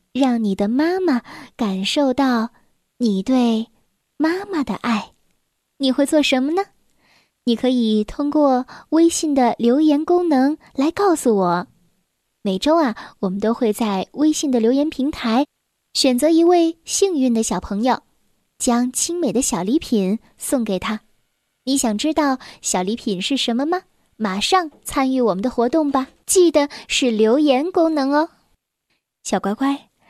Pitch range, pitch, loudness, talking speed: 225-300 Hz, 260 Hz, -19 LUFS, 205 characters per minute